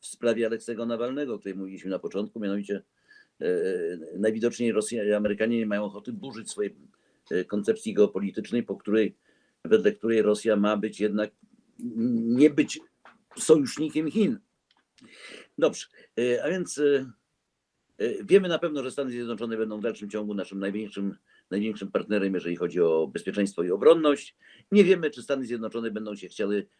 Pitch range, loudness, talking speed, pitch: 105-150 Hz, -27 LUFS, 150 wpm, 115 Hz